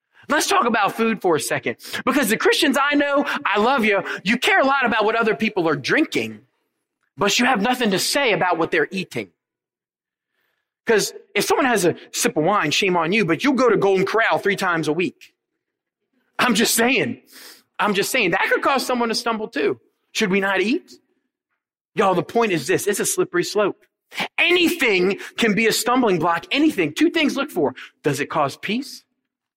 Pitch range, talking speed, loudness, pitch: 195-275 Hz, 195 wpm, -19 LUFS, 225 Hz